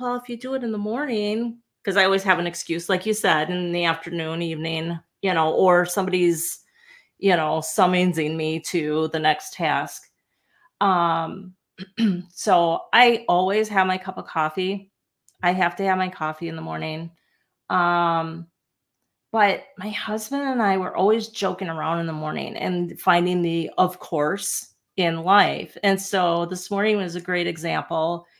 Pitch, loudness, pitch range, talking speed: 180 Hz, -22 LUFS, 165-200 Hz, 165 wpm